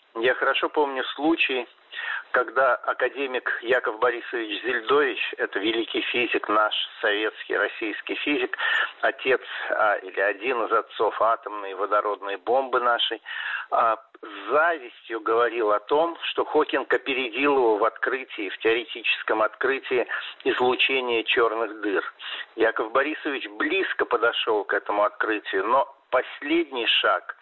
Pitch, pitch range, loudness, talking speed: 370 Hz, 305-430 Hz, -24 LUFS, 120 wpm